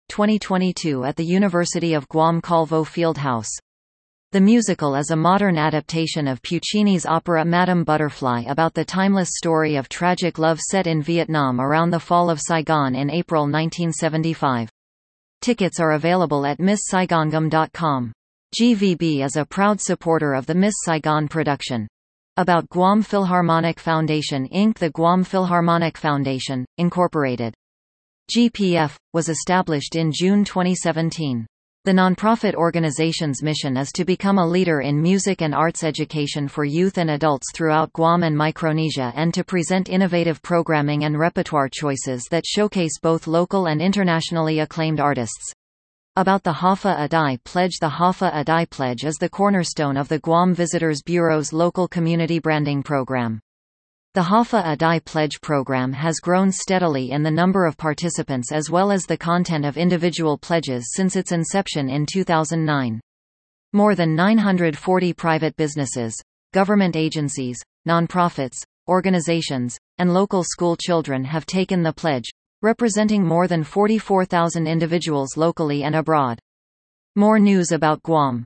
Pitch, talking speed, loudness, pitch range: 165 Hz, 140 wpm, -20 LUFS, 145-180 Hz